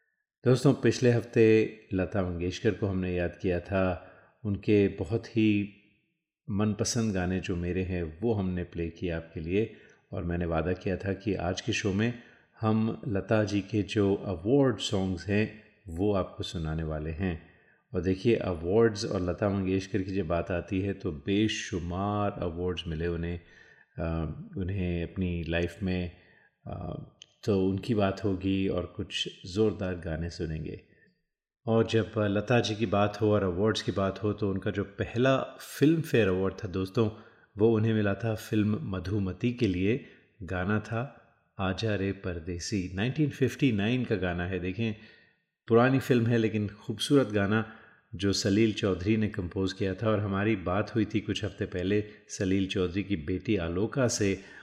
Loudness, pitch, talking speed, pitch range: -29 LUFS, 100 Hz, 155 wpm, 90-110 Hz